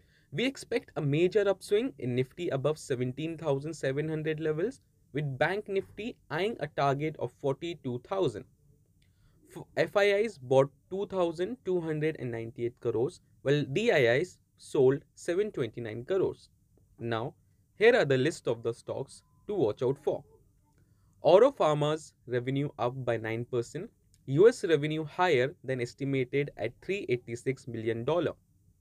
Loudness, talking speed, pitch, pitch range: -30 LUFS, 110 wpm, 145 Hz, 125-175 Hz